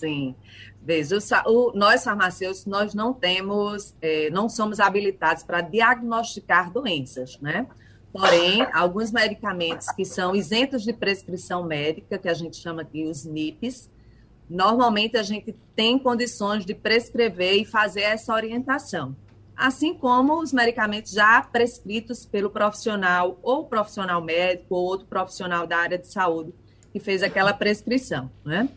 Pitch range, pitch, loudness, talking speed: 175-230 Hz, 205 Hz, -23 LUFS, 140 wpm